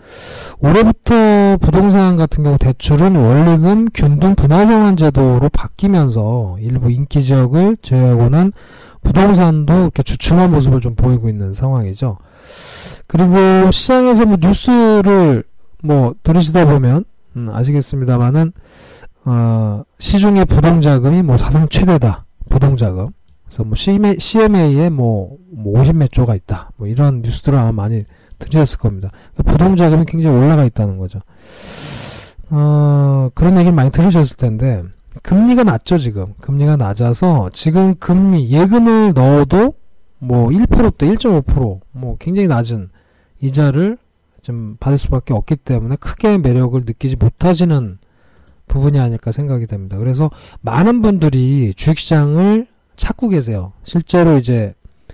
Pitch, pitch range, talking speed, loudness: 140 Hz, 120-175 Hz, 295 characters per minute, -12 LUFS